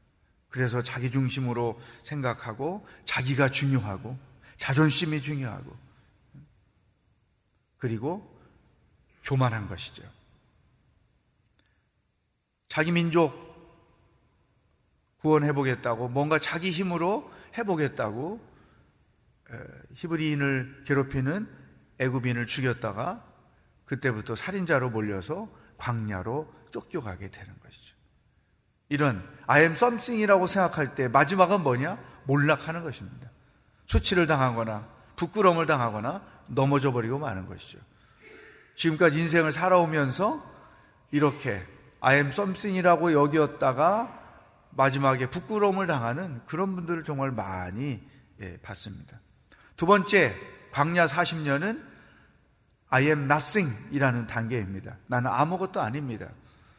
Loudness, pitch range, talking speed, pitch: -27 LUFS, 115-160 Hz, 270 characters per minute, 135 Hz